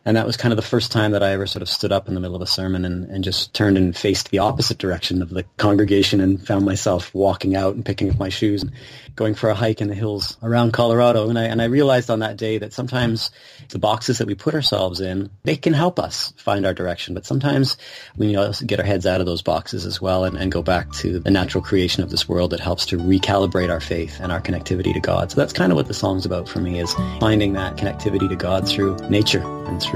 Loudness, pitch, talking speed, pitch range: -20 LUFS, 100 Hz, 270 wpm, 90-110 Hz